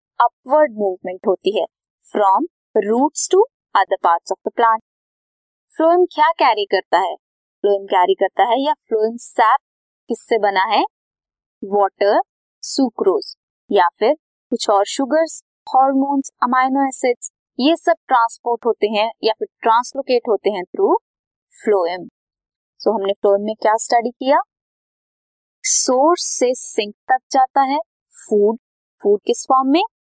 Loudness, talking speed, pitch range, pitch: -17 LUFS, 130 wpm, 210-315 Hz, 250 Hz